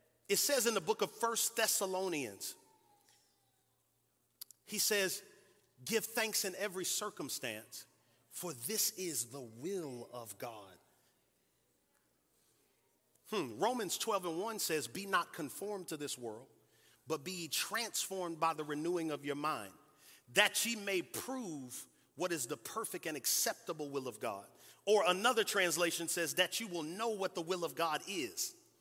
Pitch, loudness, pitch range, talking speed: 185 Hz, -36 LUFS, 155-220 Hz, 145 wpm